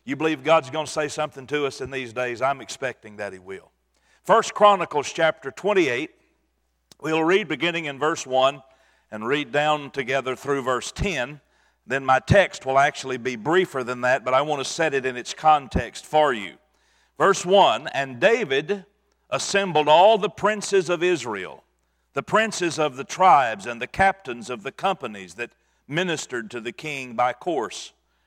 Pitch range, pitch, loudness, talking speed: 130-170 Hz, 145 Hz, -22 LUFS, 175 wpm